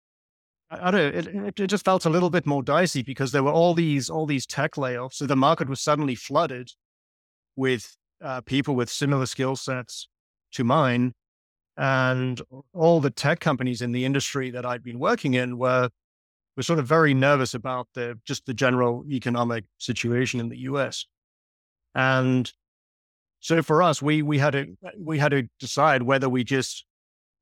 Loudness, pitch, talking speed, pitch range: -24 LUFS, 130 Hz, 175 wpm, 120-145 Hz